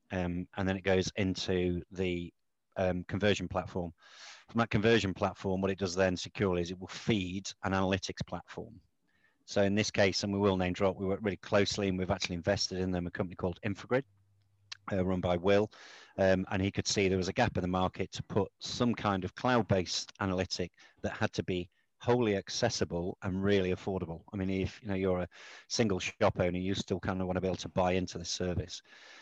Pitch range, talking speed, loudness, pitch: 90-100 Hz, 215 wpm, -33 LUFS, 95 Hz